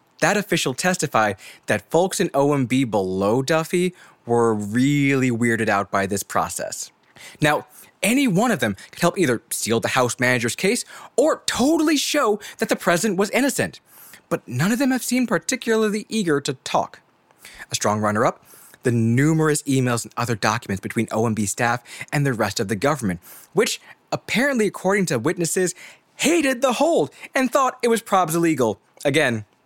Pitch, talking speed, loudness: 155 Hz, 160 wpm, -21 LUFS